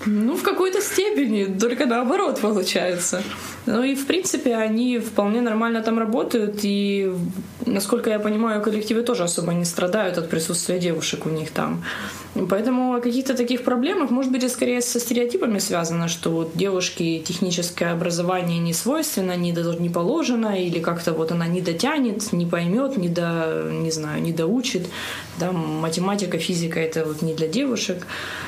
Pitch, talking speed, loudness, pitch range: 195 Hz, 160 wpm, -22 LUFS, 170-240 Hz